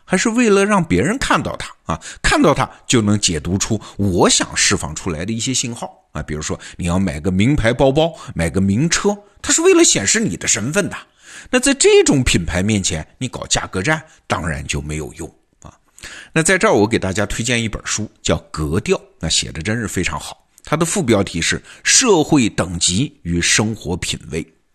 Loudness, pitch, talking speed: -17 LUFS, 105 Hz, 280 characters per minute